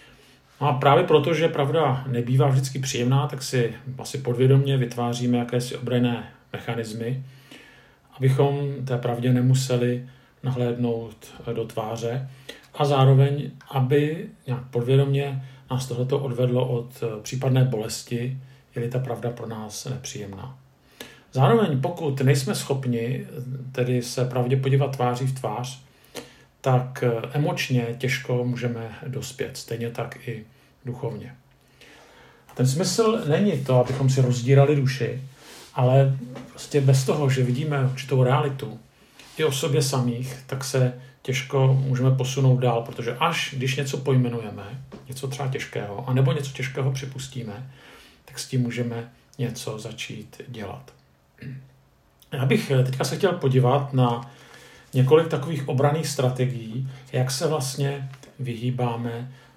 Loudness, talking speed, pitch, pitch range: -24 LUFS, 125 wpm, 130 Hz, 125-140 Hz